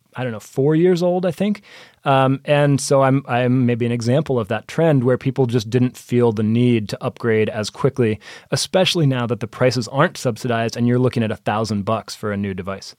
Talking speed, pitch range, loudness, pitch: 220 wpm, 115-140 Hz, -19 LUFS, 125 Hz